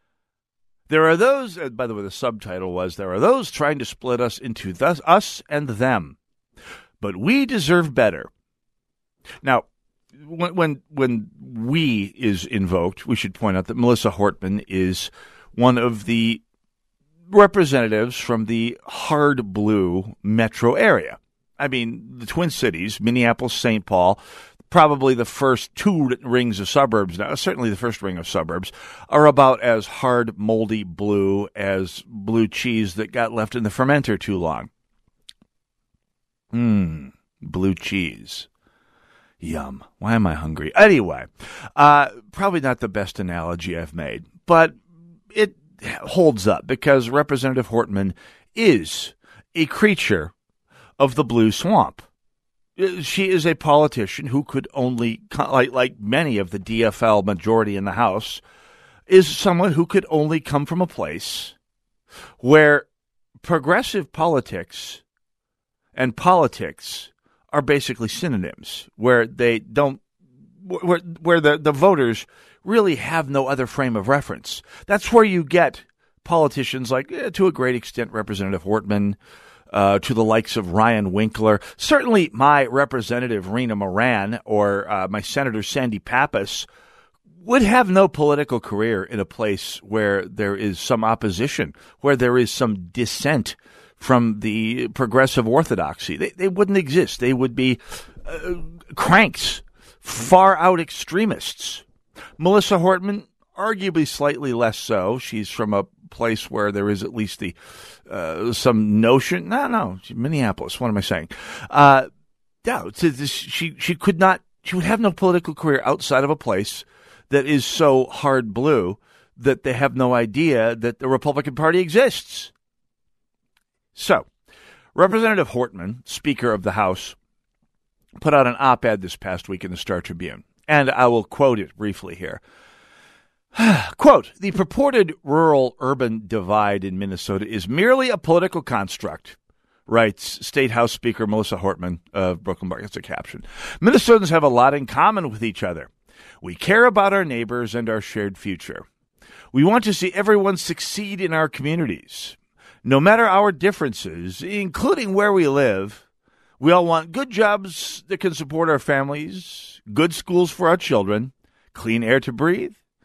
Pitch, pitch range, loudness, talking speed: 130 Hz, 110-165 Hz, -19 LUFS, 145 wpm